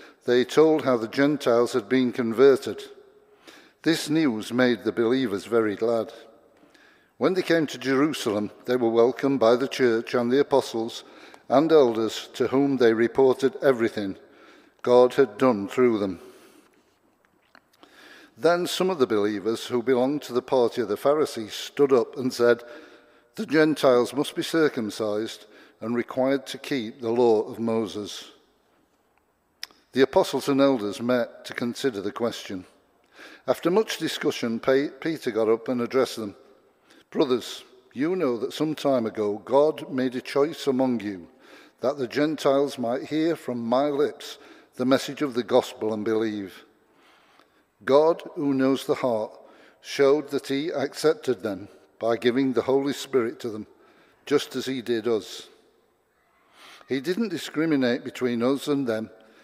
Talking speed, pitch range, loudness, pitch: 145 wpm, 115-145 Hz, -24 LUFS, 130 Hz